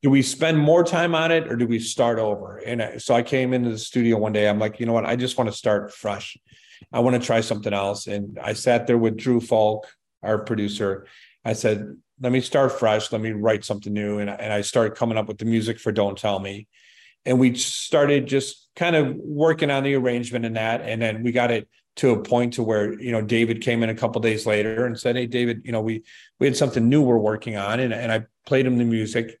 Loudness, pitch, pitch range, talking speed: -22 LUFS, 115 Hz, 110-125 Hz, 250 wpm